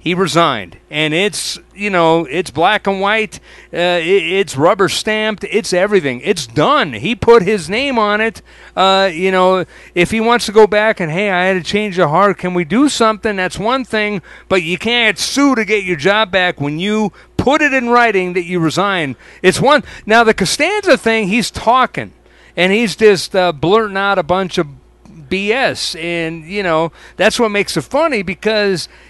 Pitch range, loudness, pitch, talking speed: 175-220 Hz, -14 LUFS, 195 Hz, 190 wpm